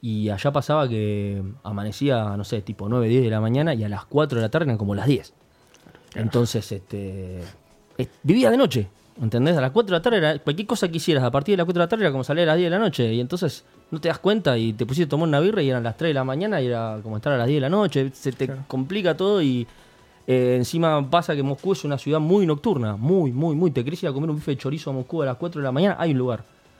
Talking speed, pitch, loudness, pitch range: 280 wpm, 140 Hz, -22 LUFS, 115-165 Hz